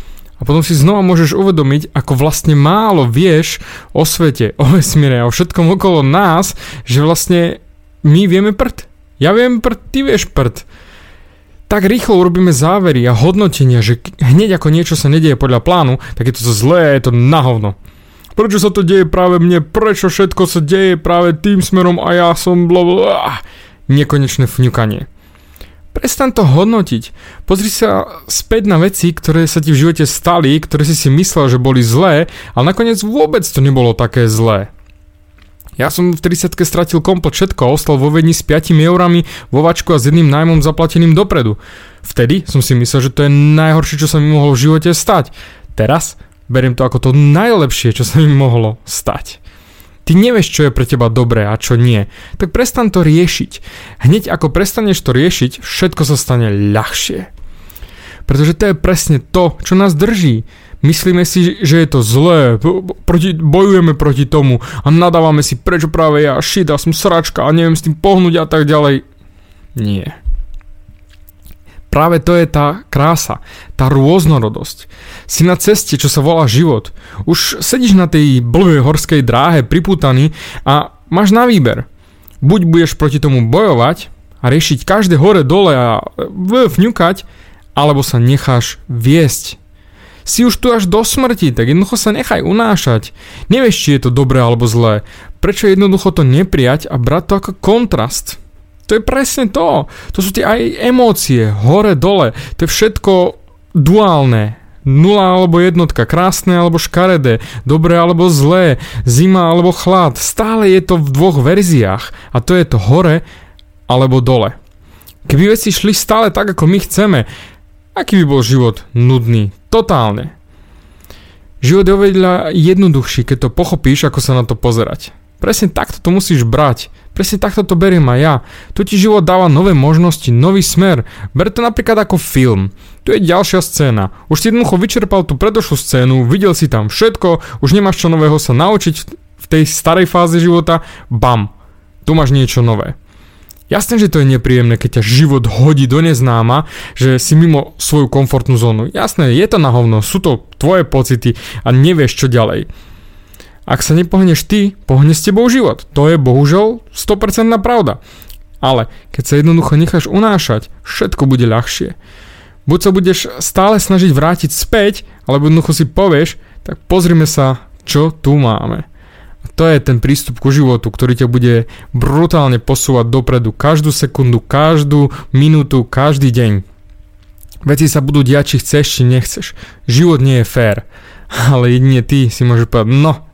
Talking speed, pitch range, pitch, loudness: 165 wpm, 120-180 Hz, 150 Hz, -10 LUFS